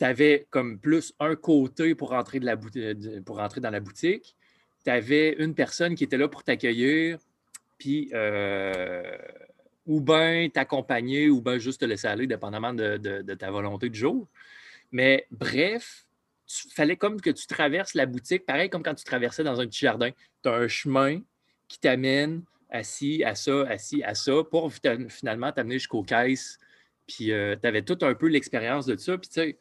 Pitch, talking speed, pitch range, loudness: 135 Hz, 195 wpm, 115-155 Hz, -26 LUFS